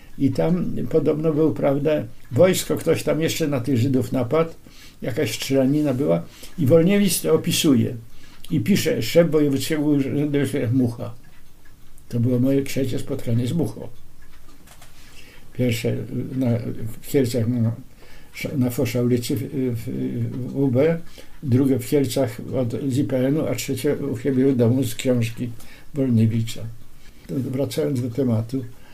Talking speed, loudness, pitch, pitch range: 135 wpm, -22 LUFS, 135 Hz, 120-145 Hz